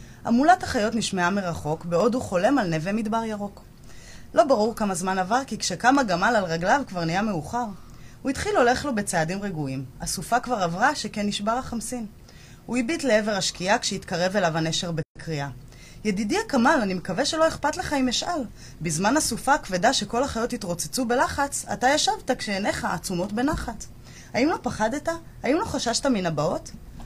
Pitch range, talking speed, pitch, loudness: 180-255 Hz, 160 wpm, 215 Hz, -24 LUFS